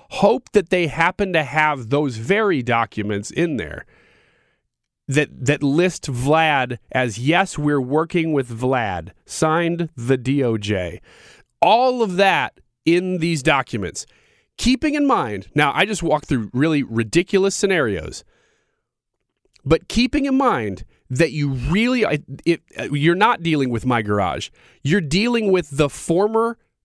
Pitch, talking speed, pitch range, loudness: 160 Hz, 135 wpm, 135-200 Hz, -19 LUFS